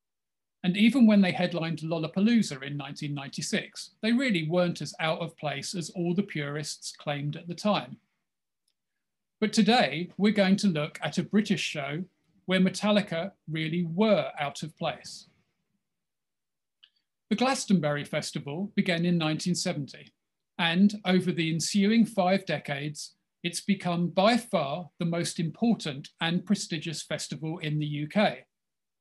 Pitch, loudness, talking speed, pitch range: 175 Hz, -28 LUFS, 135 wpm, 160-200 Hz